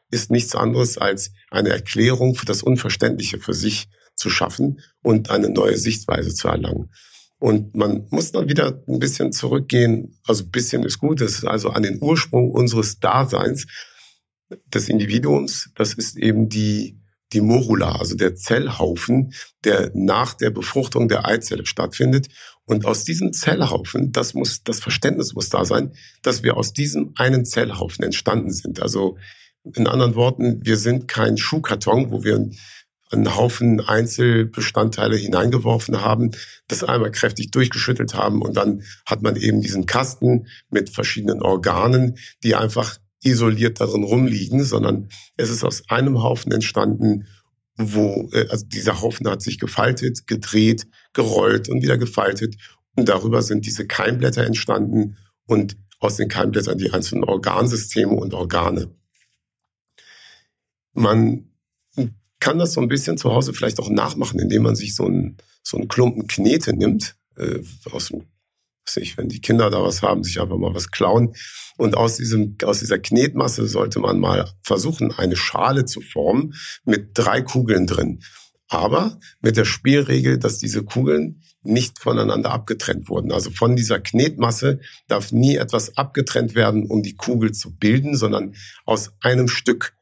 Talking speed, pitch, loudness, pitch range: 150 wpm, 115 Hz, -20 LUFS, 105-120 Hz